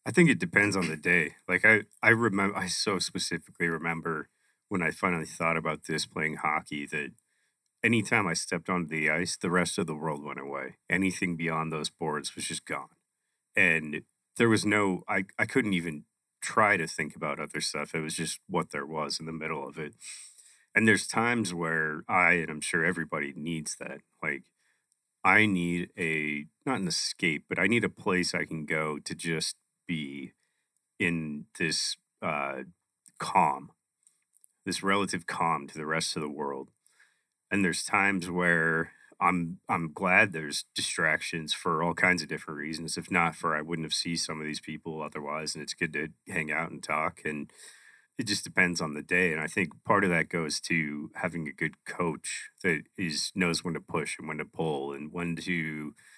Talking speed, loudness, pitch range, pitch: 190 wpm, -29 LUFS, 75-90 Hz, 80 Hz